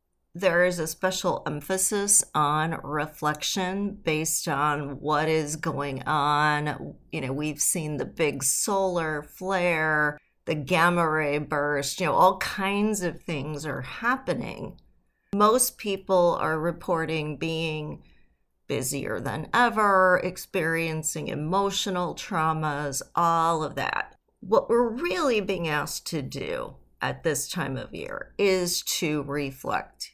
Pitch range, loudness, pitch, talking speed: 150-185 Hz, -26 LUFS, 160 Hz, 125 wpm